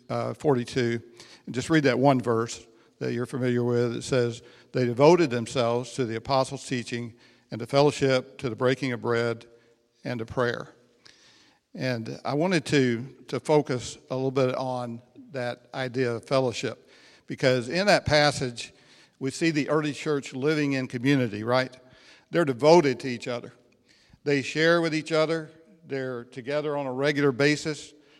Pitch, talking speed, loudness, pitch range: 130 Hz, 160 wpm, -26 LUFS, 120-145 Hz